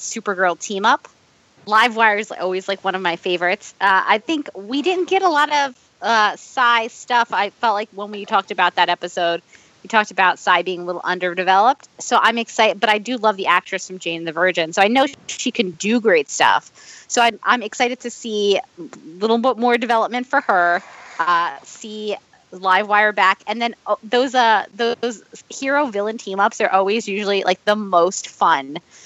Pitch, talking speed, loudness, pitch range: 210 Hz, 195 wpm, -18 LUFS, 185-240 Hz